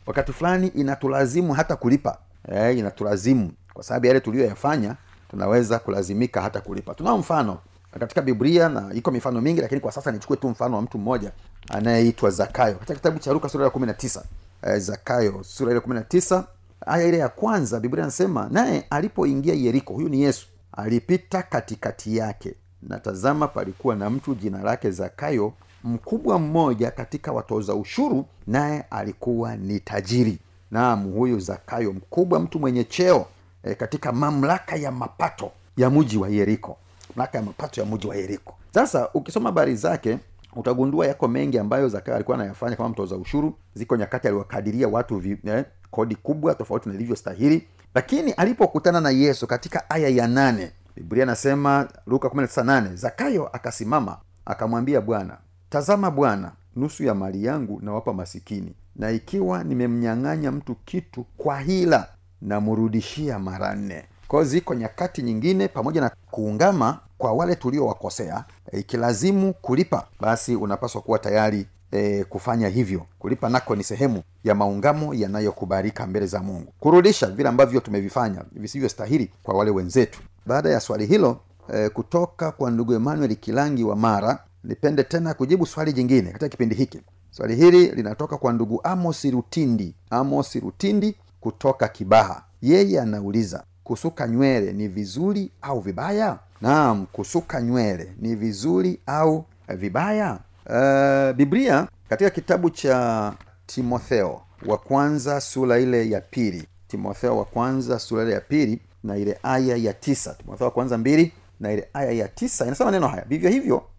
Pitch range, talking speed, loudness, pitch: 100-140 Hz, 135 wpm, -23 LUFS, 120 Hz